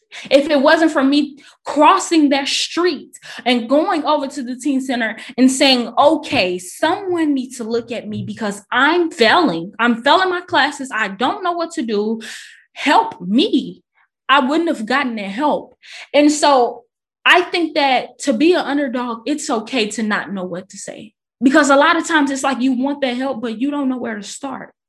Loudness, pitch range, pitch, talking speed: -16 LUFS, 235-300 Hz, 275 Hz, 195 wpm